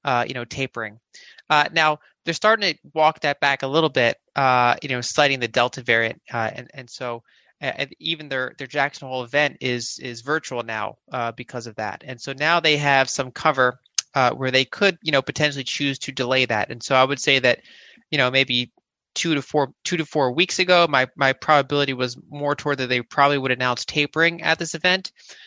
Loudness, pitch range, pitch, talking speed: -21 LUFS, 125-155 Hz, 135 Hz, 215 wpm